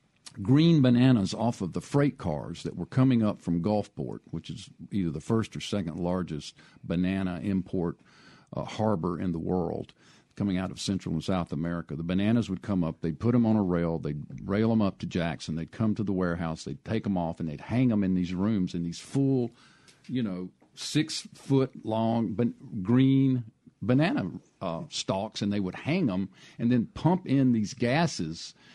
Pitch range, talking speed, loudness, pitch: 85-120 Hz, 190 wpm, -28 LUFS, 100 Hz